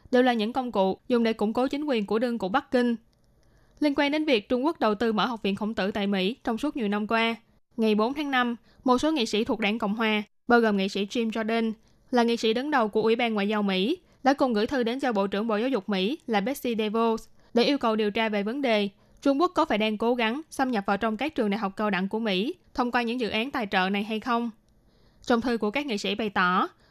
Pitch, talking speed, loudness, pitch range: 225 Hz, 280 wpm, -26 LUFS, 210-250 Hz